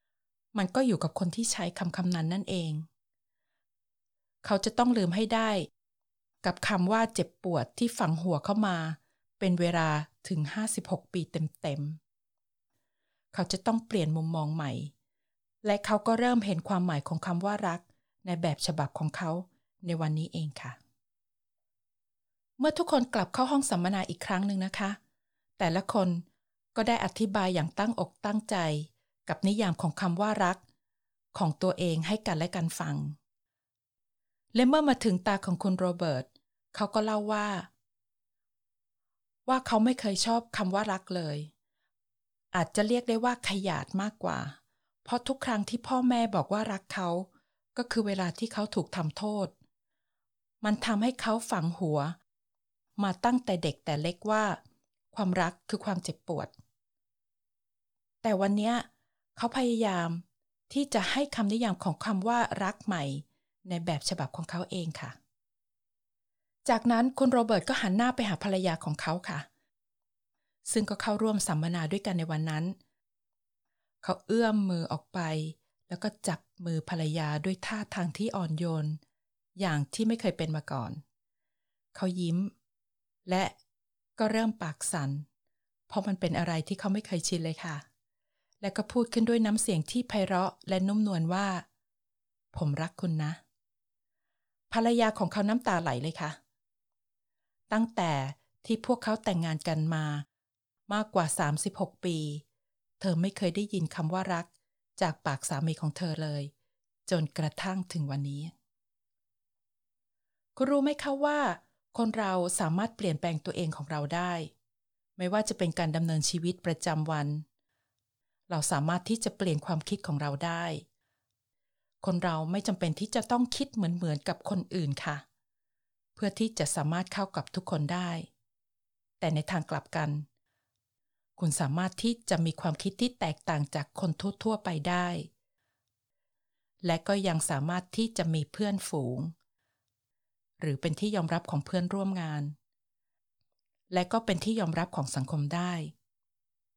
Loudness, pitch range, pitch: -31 LUFS, 150-205 Hz, 175 Hz